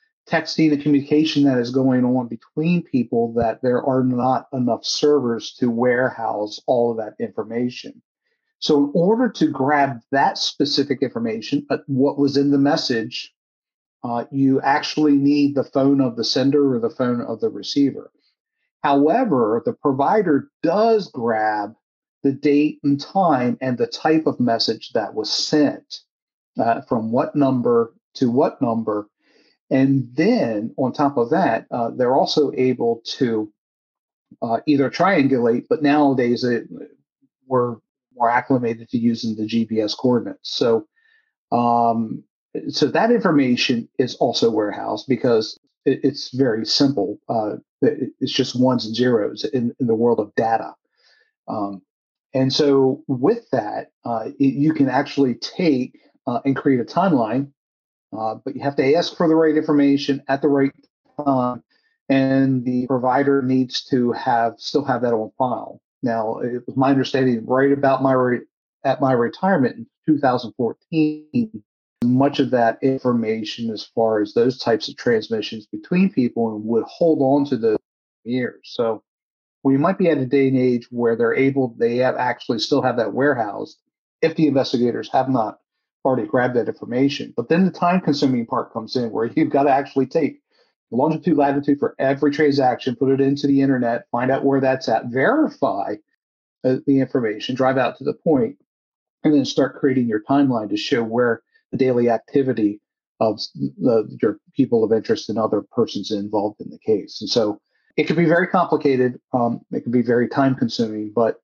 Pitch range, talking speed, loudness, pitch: 120-145 Hz, 165 wpm, -20 LUFS, 135 Hz